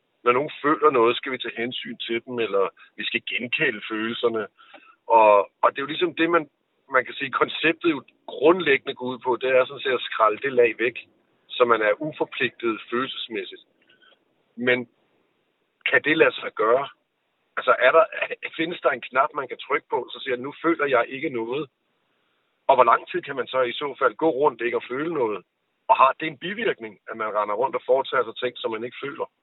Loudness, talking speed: -23 LUFS, 210 wpm